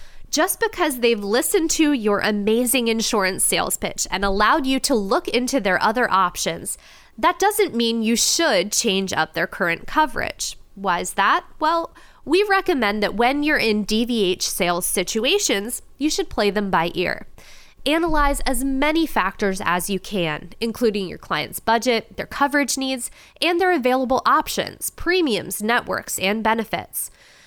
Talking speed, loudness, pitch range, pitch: 155 wpm, -20 LUFS, 200-300 Hz, 235 Hz